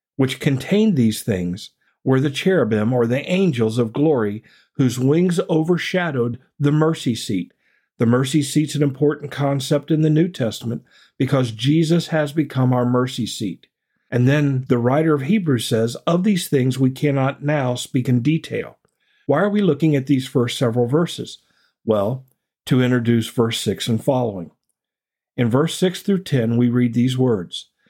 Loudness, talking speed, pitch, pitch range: -19 LUFS, 165 wpm, 135 Hz, 120-155 Hz